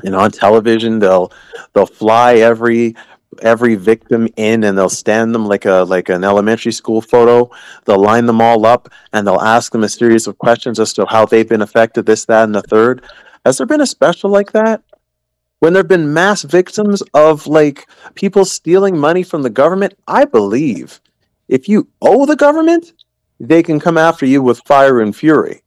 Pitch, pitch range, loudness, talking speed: 120 Hz, 110-165 Hz, -11 LUFS, 190 wpm